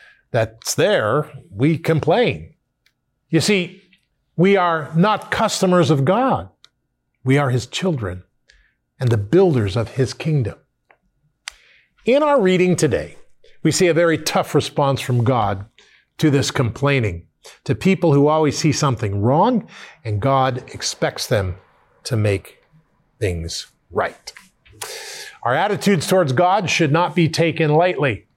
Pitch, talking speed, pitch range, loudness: 155 Hz, 130 wpm, 130-180 Hz, -18 LUFS